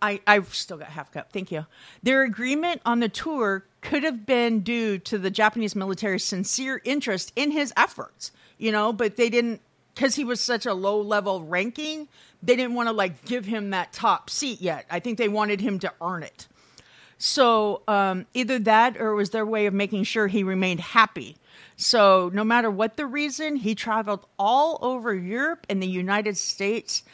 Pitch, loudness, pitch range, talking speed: 220 Hz, -24 LUFS, 200-245 Hz, 195 wpm